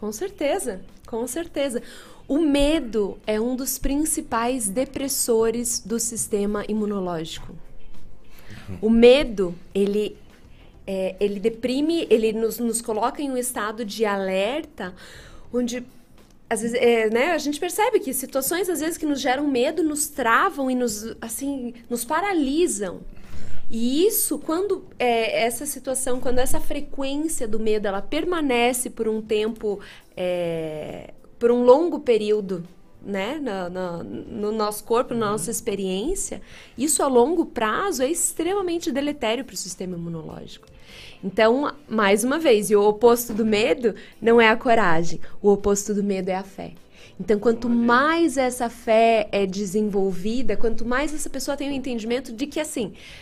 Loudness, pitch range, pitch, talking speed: -23 LUFS, 210-280 Hz, 235 Hz, 145 wpm